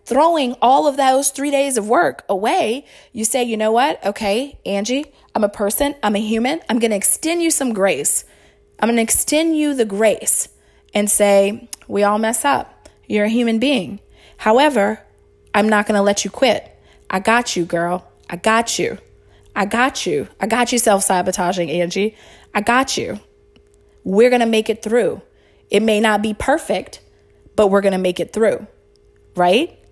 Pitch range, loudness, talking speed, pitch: 200-255 Hz, -17 LUFS, 185 wpm, 220 Hz